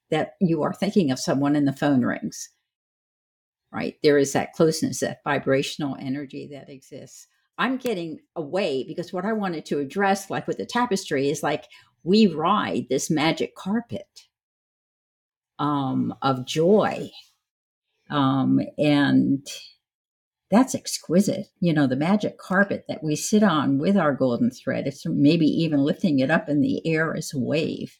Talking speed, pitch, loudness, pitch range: 155 wpm, 160 Hz, -23 LUFS, 140-195 Hz